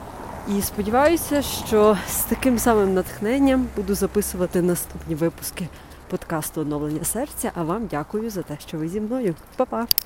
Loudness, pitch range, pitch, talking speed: -23 LUFS, 170-230 Hz, 205 Hz, 145 wpm